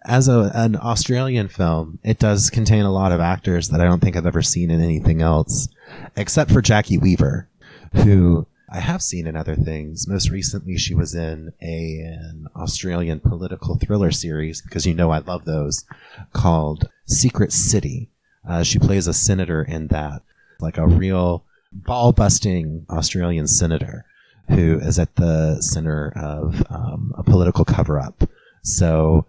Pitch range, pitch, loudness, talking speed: 80-105 Hz, 85 Hz, -19 LUFS, 160 wpm